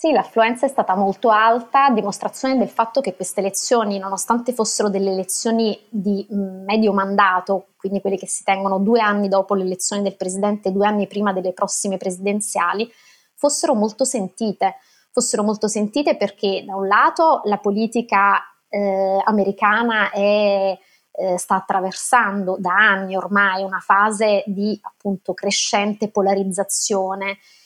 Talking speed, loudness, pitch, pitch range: 140 wpm, -19 LUFS, 200 Hz, 195-215 Hz